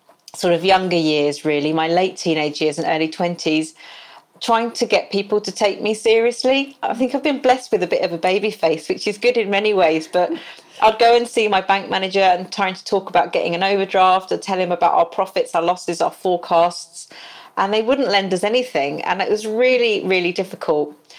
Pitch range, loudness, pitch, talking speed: 170-220 Hz, -18 LUFS, 190 Hz, 215 wpm